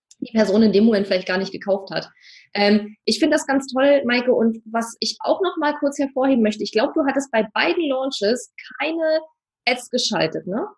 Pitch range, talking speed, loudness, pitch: 215-290 Hz, 205 wpm, -20 LUFS, 250 Hz